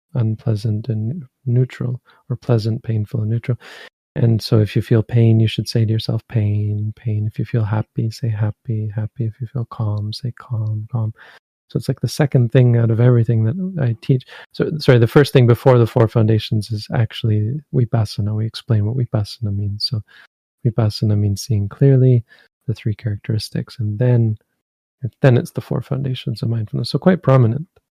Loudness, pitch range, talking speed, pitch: -18 LUFS, 110-125 Hz, 180 wpm, 115 Hz